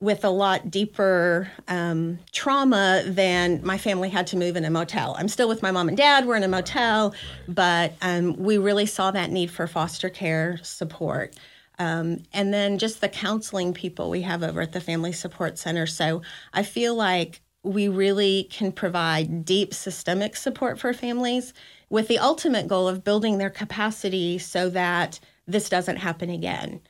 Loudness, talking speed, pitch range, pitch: -24 LUFS, 175 wpm, 175-205 Hz, 190 Hz